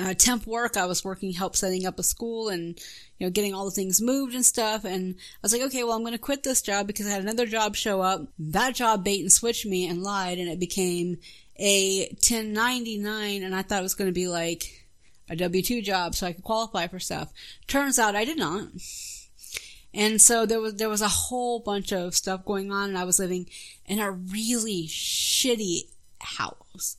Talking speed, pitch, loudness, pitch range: 220 wpm, 200 Hz, -25 LUFS, 185-225 Hz